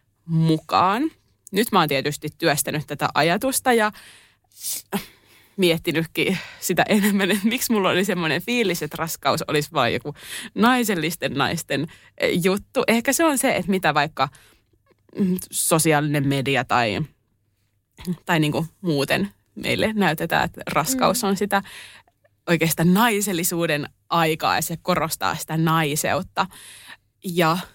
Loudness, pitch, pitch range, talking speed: -21 LUFS, 165 Hz, 150-195 Hz, 115 wpm